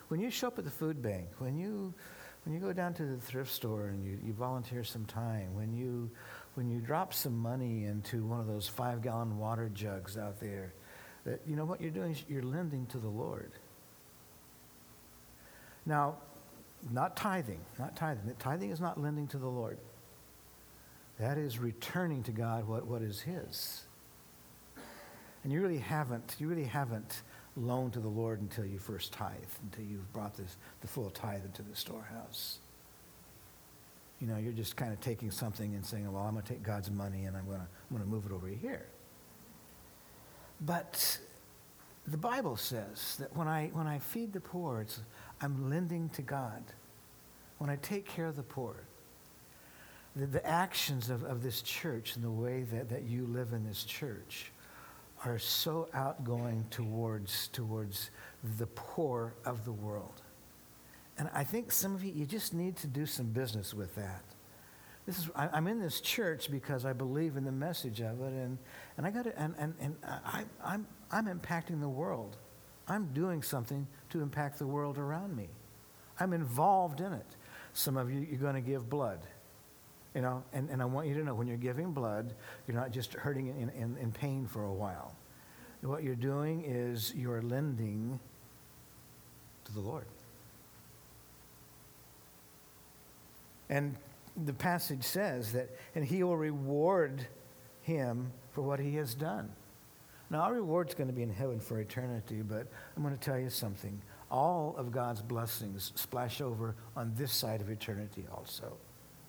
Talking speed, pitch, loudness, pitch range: 175 wpm, 125 Hz, -38 LUFS, 105-145 Hz